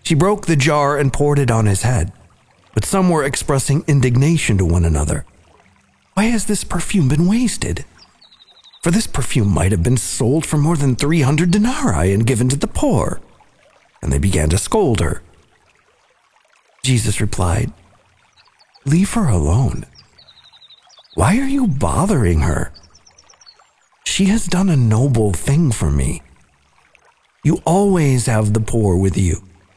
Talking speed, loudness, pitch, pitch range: 145 wpm, -16 LUFS, 125 Hz, 95-160 Hz